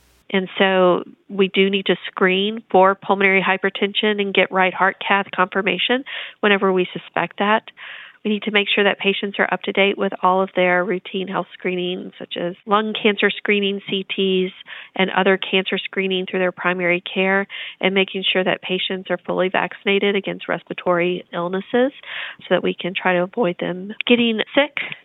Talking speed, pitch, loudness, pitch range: 175 wpm, 190 Hz, -19 LUFS, 185-200 Hz